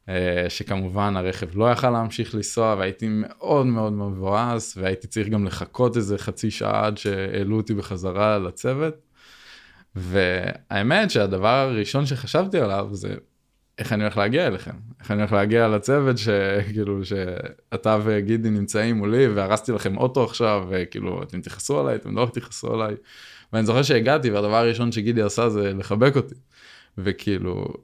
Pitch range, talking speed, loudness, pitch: 100-115 Hz, 140 wpm, -23 LUFS, 105 Hz